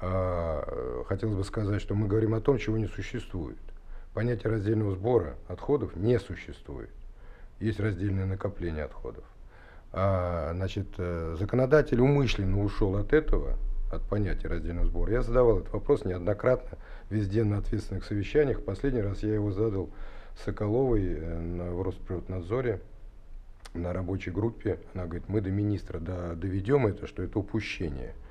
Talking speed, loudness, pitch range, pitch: 130 wpm, -30 LUFS, 90-110 Hz, 100 Hz